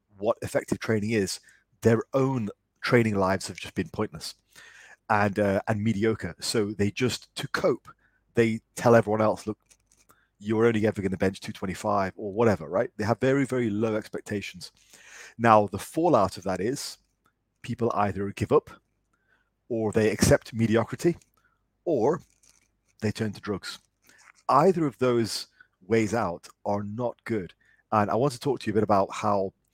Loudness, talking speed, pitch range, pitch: -26 LUFS, 160 wpm, 100-115 Hz, 110 Hz